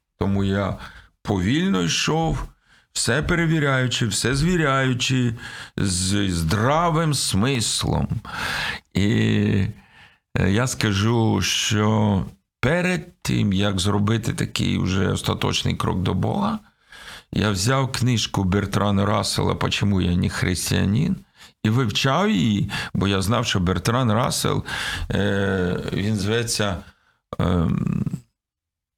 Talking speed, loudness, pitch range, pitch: 95 wpm, -22 LUFS, 100-130 Hz, 110 Hz